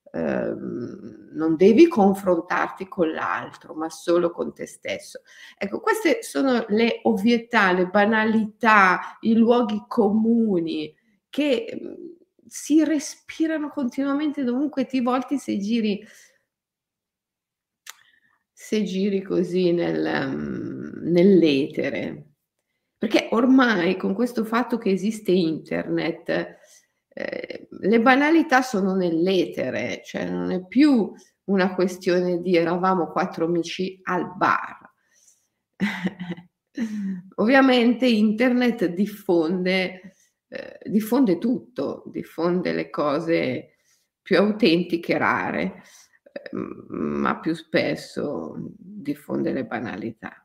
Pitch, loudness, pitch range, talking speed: 205 Hz, -22 LUFS, 175-245 Hz, 100 wpm